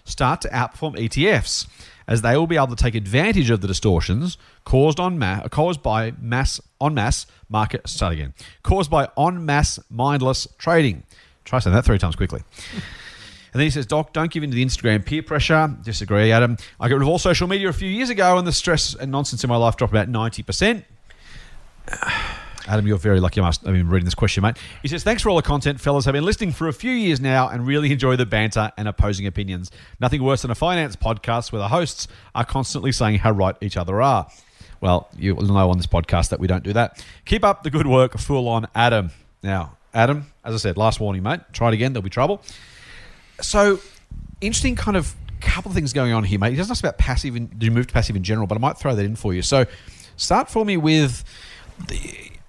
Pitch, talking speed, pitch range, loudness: 115 Hz, 225 wpm, 100-145 Hz, -20 LUFS